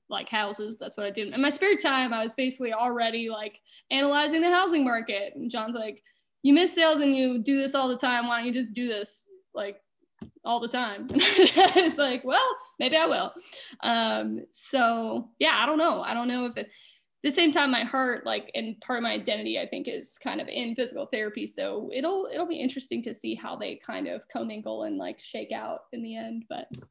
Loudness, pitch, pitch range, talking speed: -26 LUFS, 255 Hz, 230-310 Hz, 220 wpm